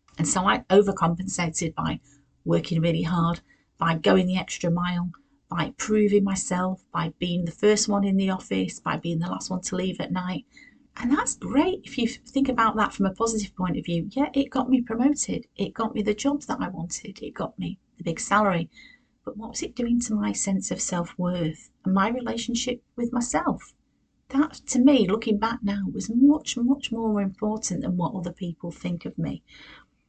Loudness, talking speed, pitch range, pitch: -25 LUFS, 200 wpm, 180-245 Hz, 205 Hz